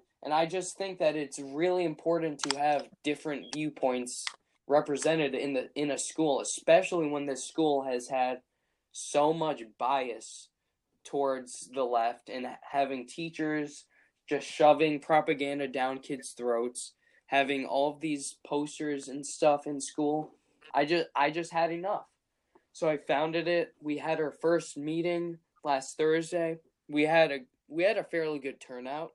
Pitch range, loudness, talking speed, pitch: 140-160 Hz, -31 LUFS, 150 wpm, 150 Hz